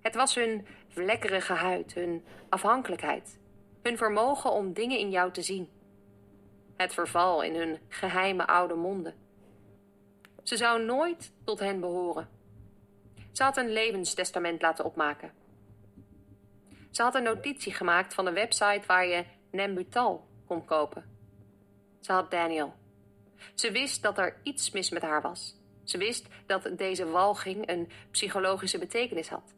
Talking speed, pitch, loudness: 140 wpm, 175 Hz, -30 LUFS